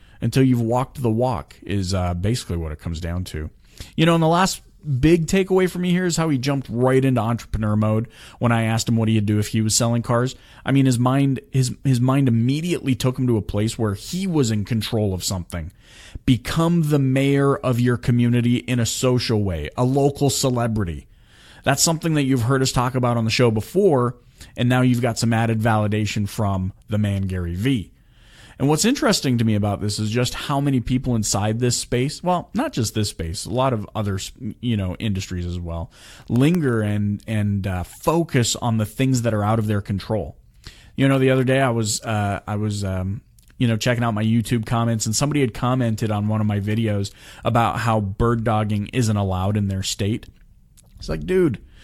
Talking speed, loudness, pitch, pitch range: 205 wpm, -21 LUFS, 115 Hz, 105-130 Hz